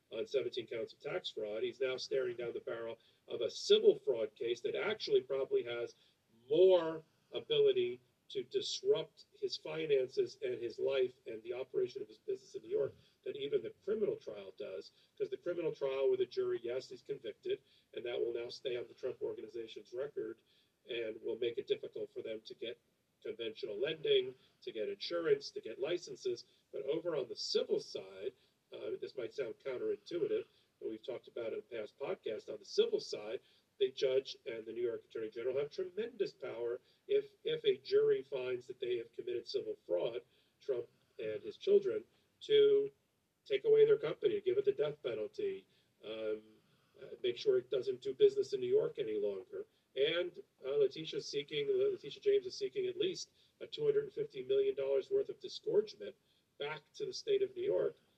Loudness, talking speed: -37 LUFS, 185 wpm